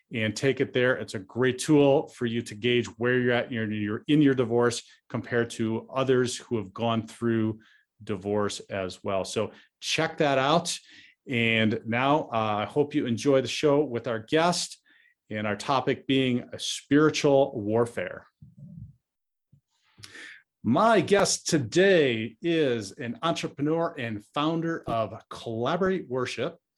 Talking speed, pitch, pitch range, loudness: 140 wpm, 120 Hz, 115-145 Hz, -26 LUFS